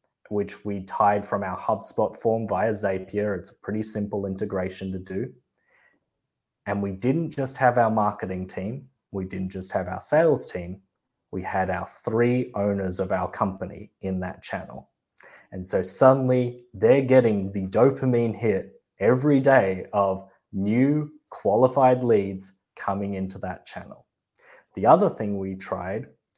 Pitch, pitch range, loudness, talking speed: 100 Hz, 95-120 Hz, -24 LUFS, 150 wpm